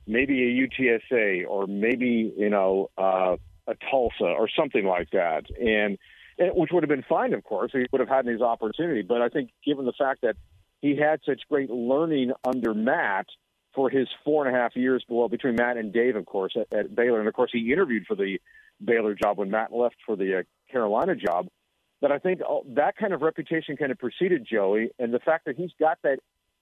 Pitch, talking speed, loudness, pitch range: 125 Hz, 220 wpm, -25 LUFS, 115-150 Hz